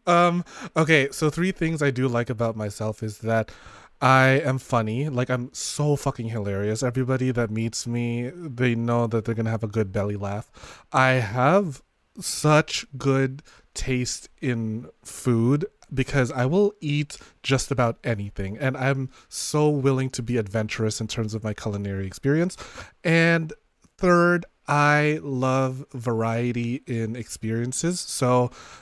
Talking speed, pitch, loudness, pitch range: 145 wpm, 130 Hz, -24 LUFS, 115-145 Hz